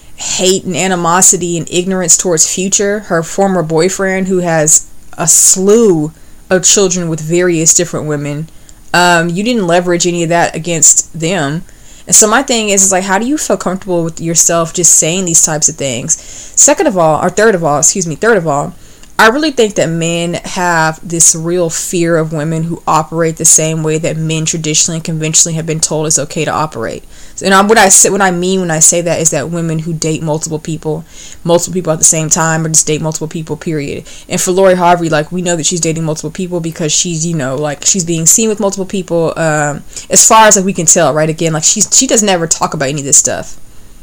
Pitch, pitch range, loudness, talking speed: 170 Hz, 155-185 Hz, -10 LUFS, 225 wpm